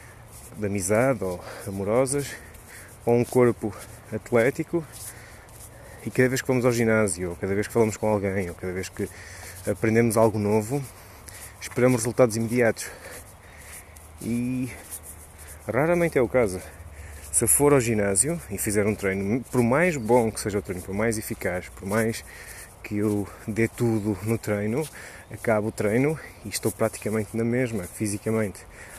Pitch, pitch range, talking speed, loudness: 110 Hz, 95-115 Hz, 150 wpm, -25 LUFS